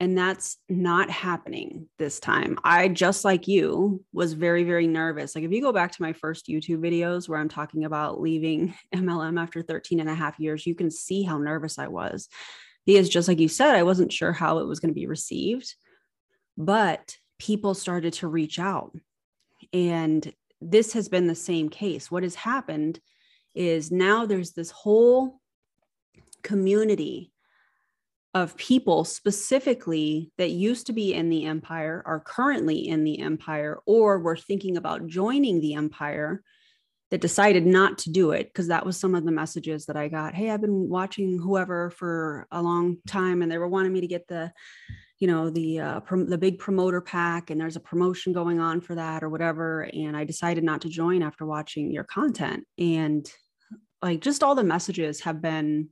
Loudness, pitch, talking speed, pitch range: -25 LUFS, 175 Hz, 185 wpm, 160-190 Hz